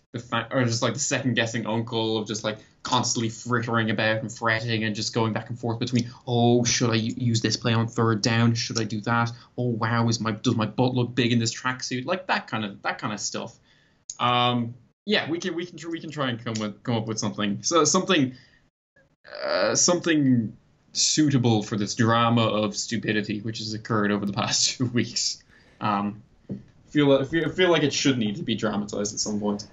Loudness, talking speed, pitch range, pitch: -24 LUFS, 210 wpm, 110-125 Hz, 115 Hz